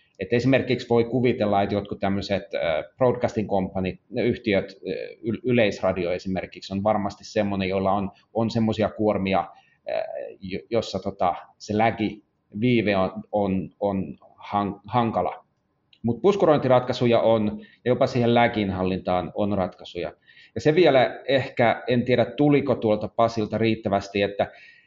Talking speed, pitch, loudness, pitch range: 120 wpm, 105 Hz, -24 LUFS, 100-120 Hz